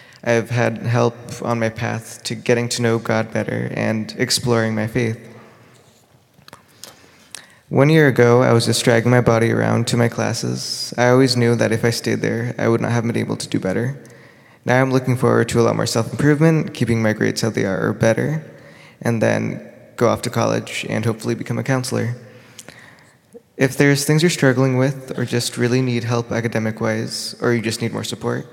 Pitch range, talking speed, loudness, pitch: 115-125 Hz, 200 wpm, -18 LUFS, 120 Hz